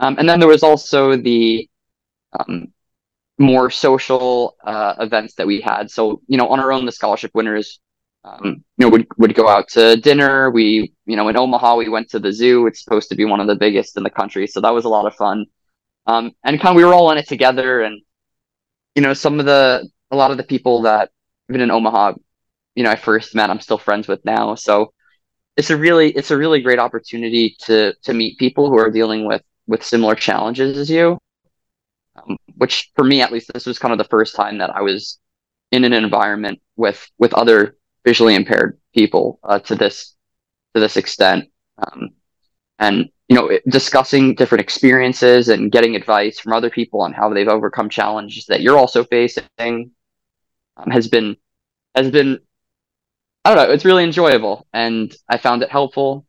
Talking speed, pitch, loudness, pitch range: 200 wpm, 120 Hz, -15 LUFS, 110-135 Hz